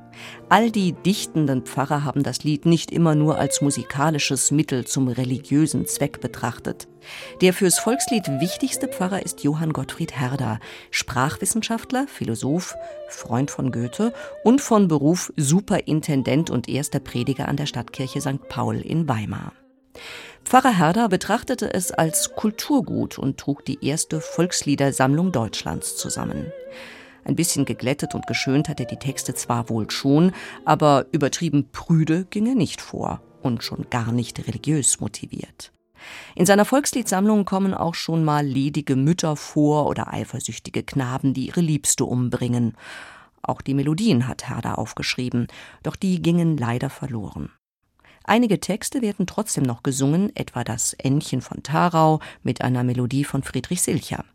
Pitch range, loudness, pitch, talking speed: 130-185 Hz, -22 LUFS, 150 Hz, 140 wpm